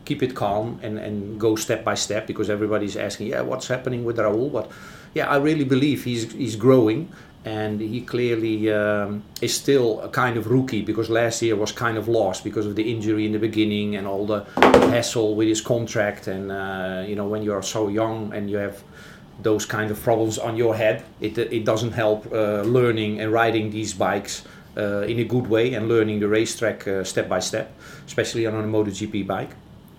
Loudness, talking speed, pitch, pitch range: -23 LUFS, 210 wpm, 110 Hz, 105-115 Hz